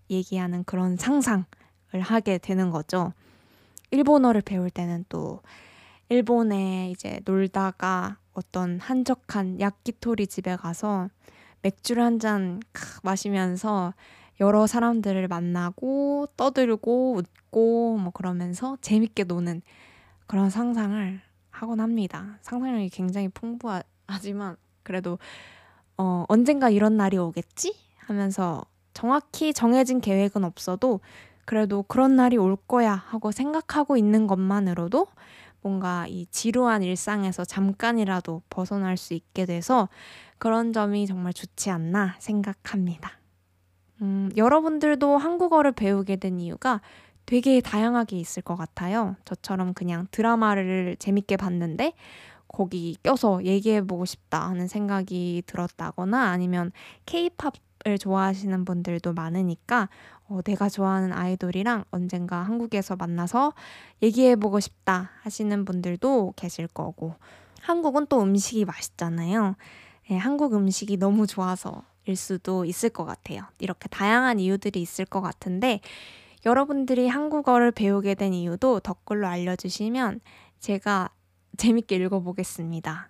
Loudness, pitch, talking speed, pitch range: -25 LUFS, 195 Hz, 285 characters per minute, 180-230 Hz